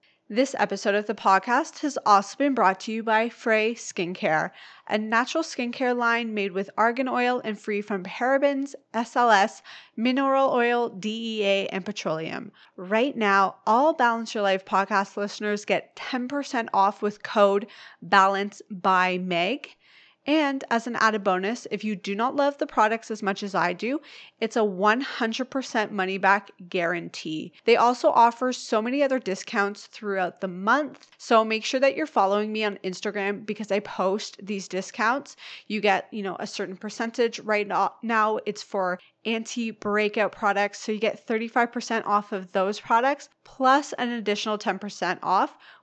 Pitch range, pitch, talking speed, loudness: 200-240 Hz, 215 Hz, 155 wpm, -25 LUFS